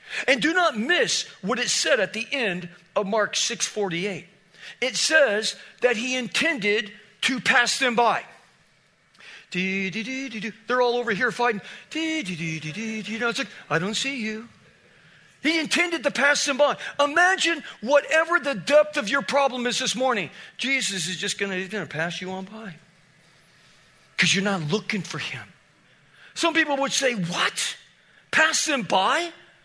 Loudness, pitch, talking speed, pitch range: -23 LUFS, 235 Hz, 160 wpm, 195-280 Hz